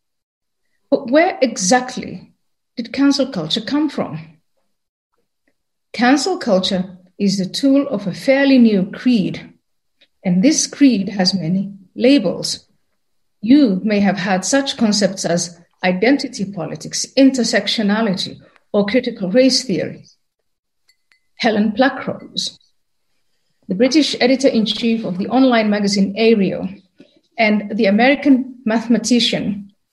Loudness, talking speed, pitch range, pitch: -16 LUFS, 105 wpm, 195-260 Hz, 225 Hz